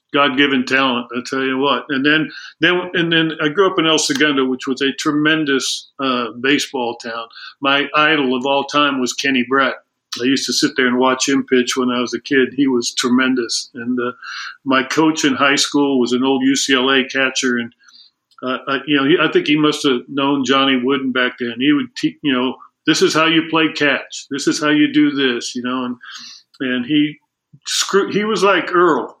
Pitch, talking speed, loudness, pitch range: 135 Hz, 215 wpm, -16 LUFS, 130-150 Hz